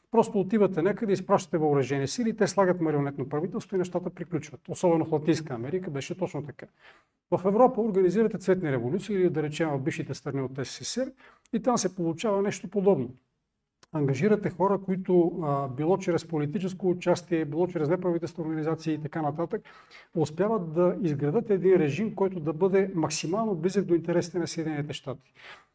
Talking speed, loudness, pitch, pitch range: 160 wpm, -27 LUFS, 175 Hz, 155-195 Hz